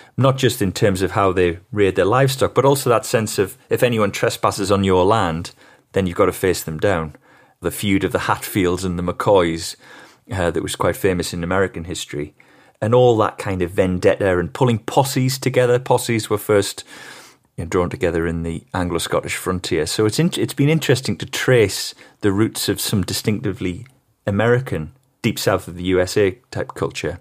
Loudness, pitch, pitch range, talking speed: -19 LUFS, 100 Hz, 90-120 Hz, 190 wpm